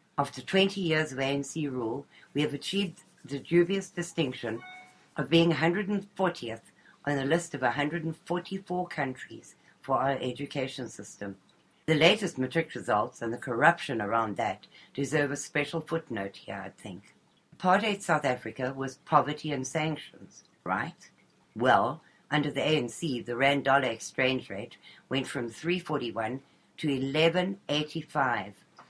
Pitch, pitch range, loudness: 145 Hz, 125-170 Hz, -29 LUFS